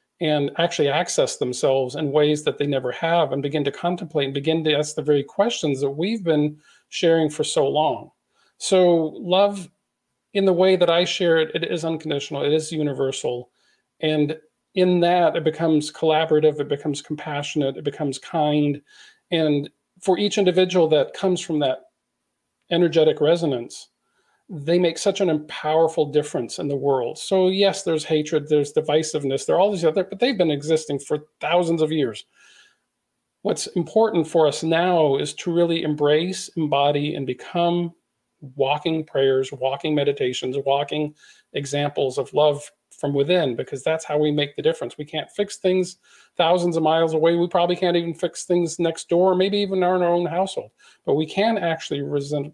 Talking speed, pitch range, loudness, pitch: 170 wpm, 150-175 Hz, -21 LUFS, 160 Hz